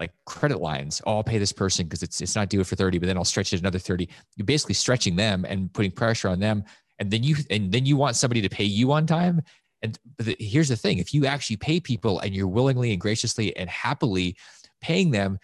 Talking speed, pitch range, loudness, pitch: 240 wpm, 95-125 Hz, -24 LUFS, 105 Hz